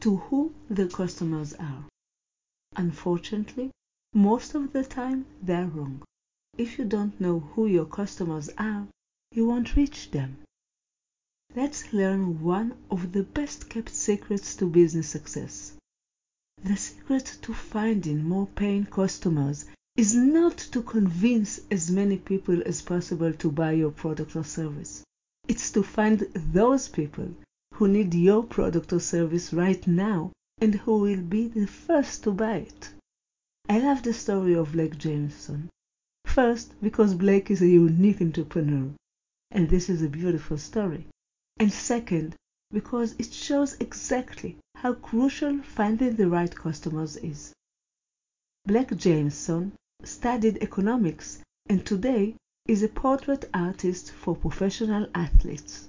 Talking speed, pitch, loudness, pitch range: 135 wpm, 195 Hz, -26 LUFS, 170-225 Hz